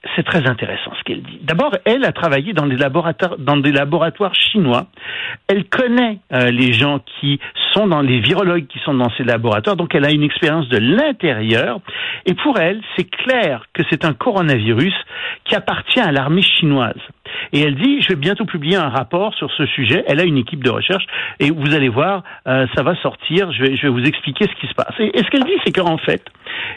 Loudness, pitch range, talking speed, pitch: -16 LUFS, 140-195 Hz, 215 wpm, 160 Hz